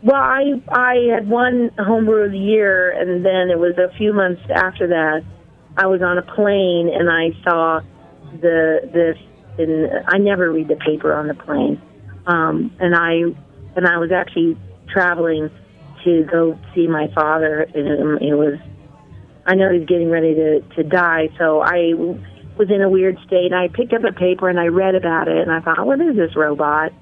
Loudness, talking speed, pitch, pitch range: -17 LUFS, 195 wpm, 170 Hz, 160-190 Hz